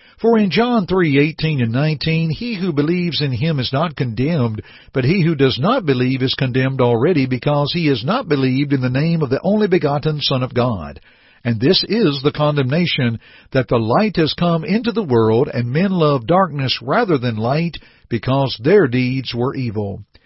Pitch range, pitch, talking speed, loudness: 125-165 Hz, 140 Hz, 190 wpm, -17 LUFS